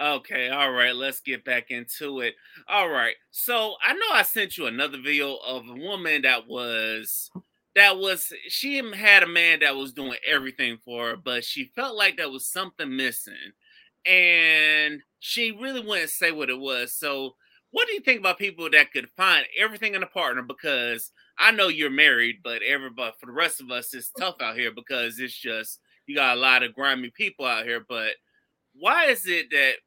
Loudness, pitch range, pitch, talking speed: -22 LUFS, 130-200 Hz, 150 Hz, 195 wpm